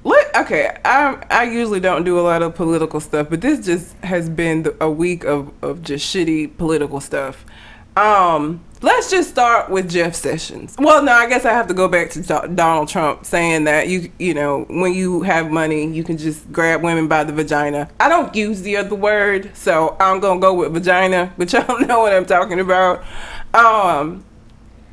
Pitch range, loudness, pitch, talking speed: 155-195 Hz, -16 LUFS, 175 Hz, 195 wpm